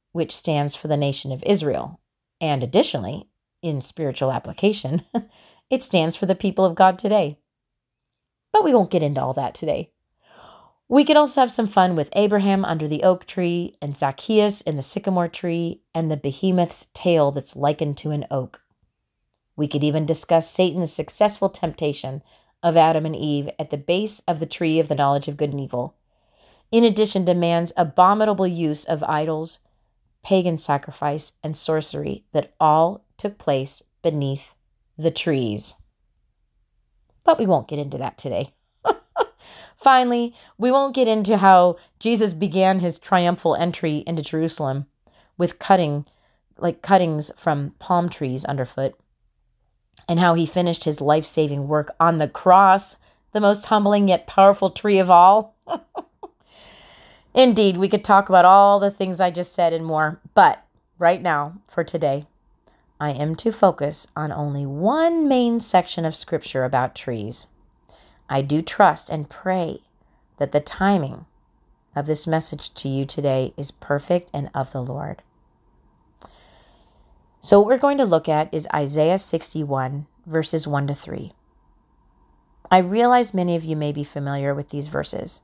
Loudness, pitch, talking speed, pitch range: -20 LUFS, 165 Hz, 155 wpm, 145-190 Hz